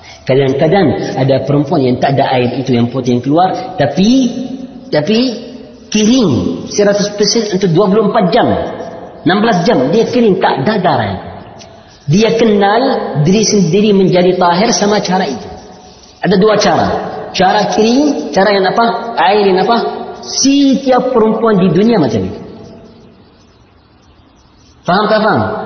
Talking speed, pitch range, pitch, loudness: 130 wpm, 150-230 Hz, 205 Hz, -11 LUFS